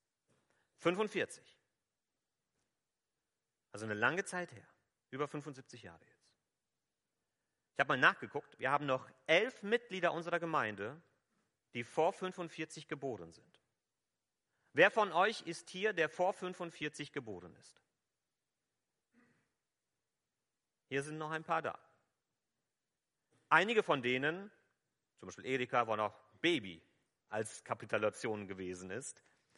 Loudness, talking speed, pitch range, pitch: -36 LUFS, 110 wpm, 125-175 Hz, 155 Hz